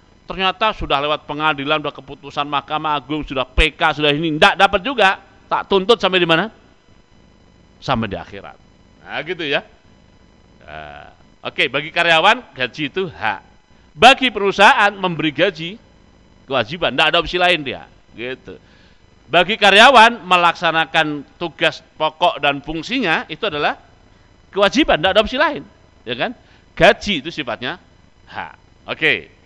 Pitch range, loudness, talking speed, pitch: 140-190 Hz, -16 LUFS, 130 wpm, 160 Hz